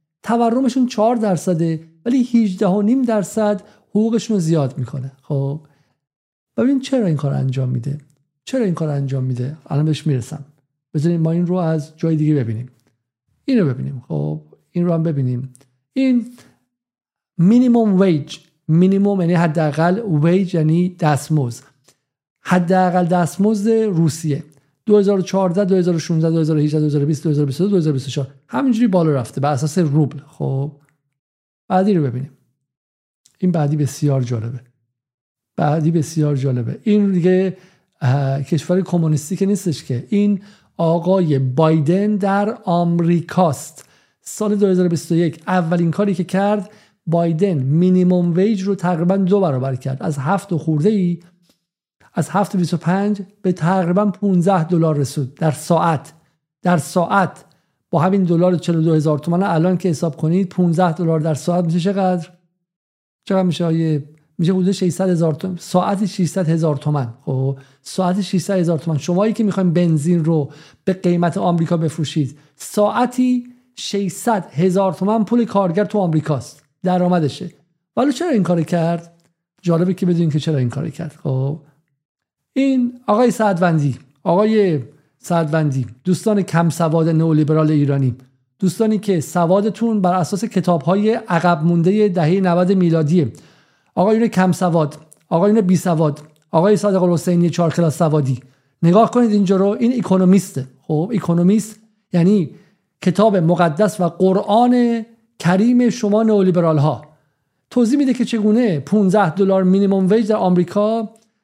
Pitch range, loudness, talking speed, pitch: 150-195 Hz, -17 LUFS, 130 wpm, 175 Hz